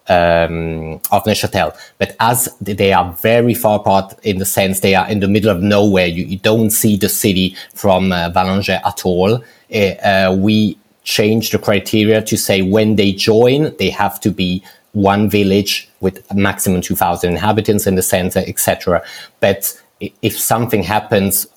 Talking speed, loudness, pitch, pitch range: 170 wpm, -14 LUFS, 100 Hz, 95-105 Hz